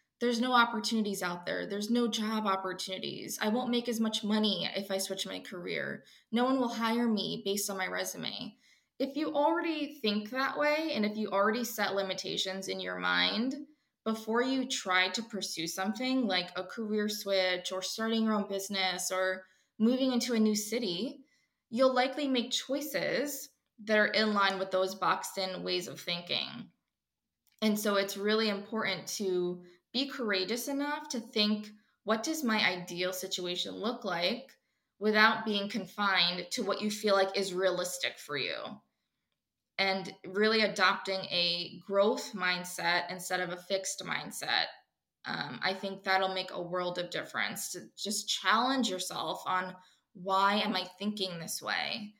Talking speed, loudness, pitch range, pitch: 160 wpm, -32 LUFS, 185-235 Hz, 205 Hz